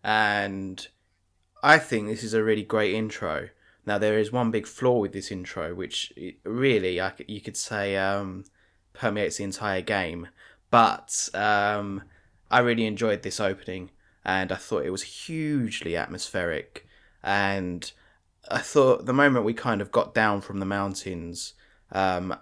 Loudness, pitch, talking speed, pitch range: -26 LUFS, 100 Hz, 155 wpm, 95-110 Hz